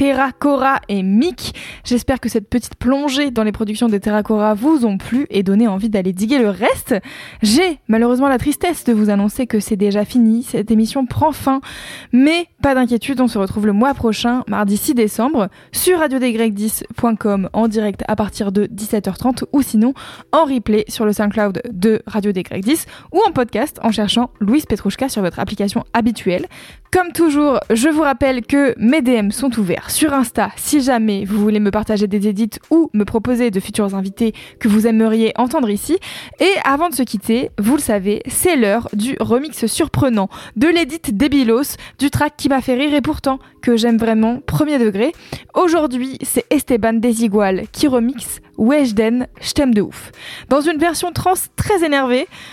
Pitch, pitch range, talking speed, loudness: 235 Hz, 215-275 Hz, 180 wpm, -16 LUFS